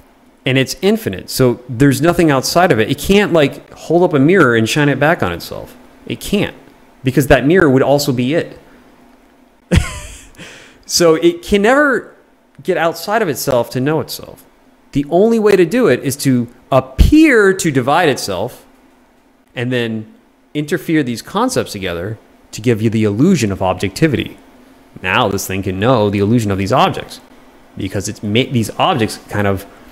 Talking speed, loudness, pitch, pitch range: 170 wpm, -14 LUFS, 135 Hz, 110-165 Hz